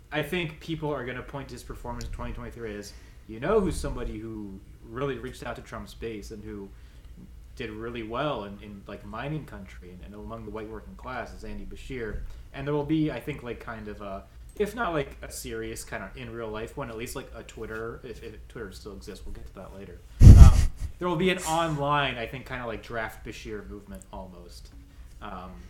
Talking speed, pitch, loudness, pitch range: 225 wpm, 110 Hz, -27 LUFS, 100-130 Hz